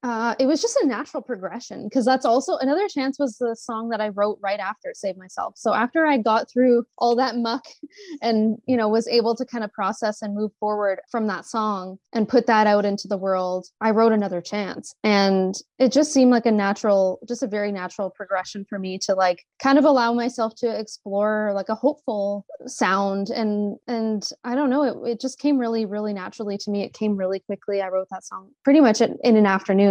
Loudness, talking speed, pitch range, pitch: -22 LUFS, 220 wpm, 200-245 Hz, 220 Hz